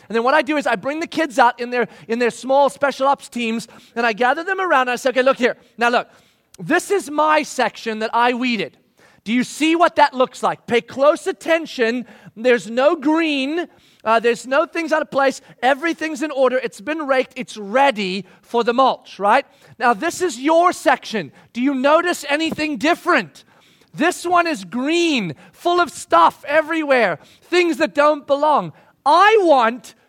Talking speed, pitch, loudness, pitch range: 190 wpm, 270 Hz, -18 LUFS, 235-315 Hz